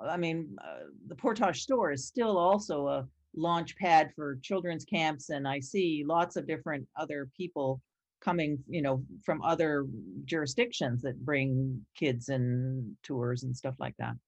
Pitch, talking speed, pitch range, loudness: 150 Hz, 160 wpm, 130-170 Hz, -32 LUFS